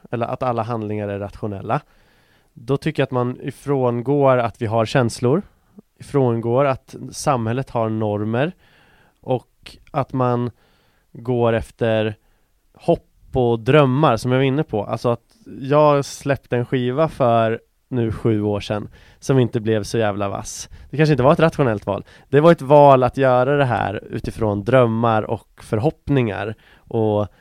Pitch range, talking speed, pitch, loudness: 110-135 Hz, 155 wpm, 120 Hz, -19 LUFS